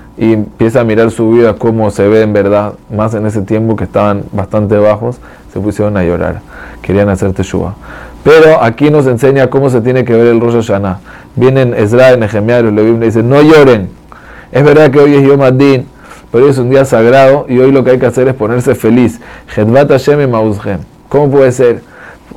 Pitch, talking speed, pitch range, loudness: 115 Hz, 195 wpm, 105-130 Hz, -8 LUFS